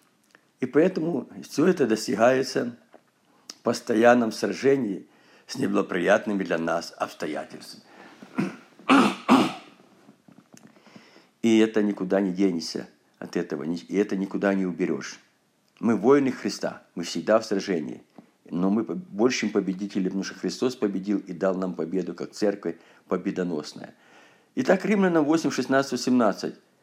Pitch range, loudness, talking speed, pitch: 95-120 Hz, -25 LUFS, 115 wpm, 100 Hz